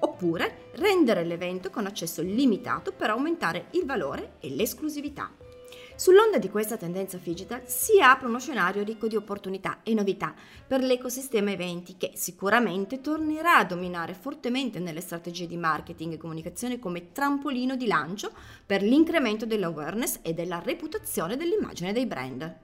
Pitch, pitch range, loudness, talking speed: 215 Hz, 175-270 Hz, -27 LUFS, 145 wpm